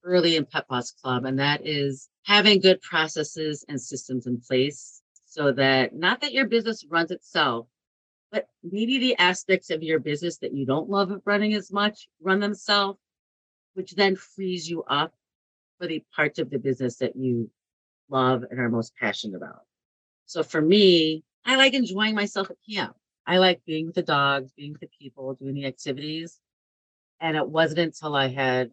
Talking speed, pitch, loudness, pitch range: 180 wpm, 155 Hz, -24 LUFS, 130-185 Hz